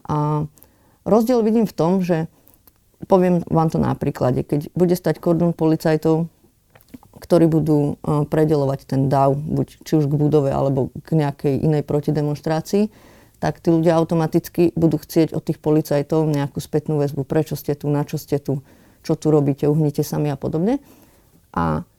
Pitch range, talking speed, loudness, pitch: 145-165 Hz, 160 wpm, -20 LUFS, 155 Hz